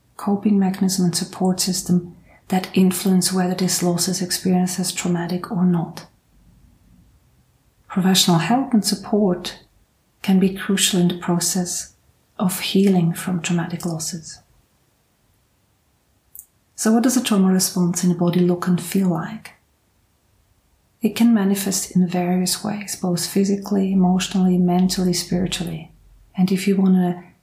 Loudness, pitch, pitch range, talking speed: -19 LUFS, 180 Hz, 175-190 Hz, 130 wpm